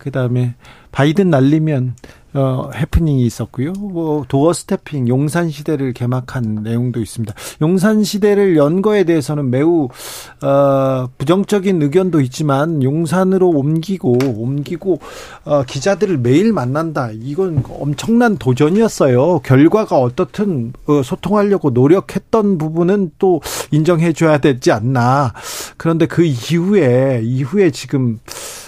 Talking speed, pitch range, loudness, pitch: 280 characters per minute, 130-180 Hz, -15 LUFS, 150 Hz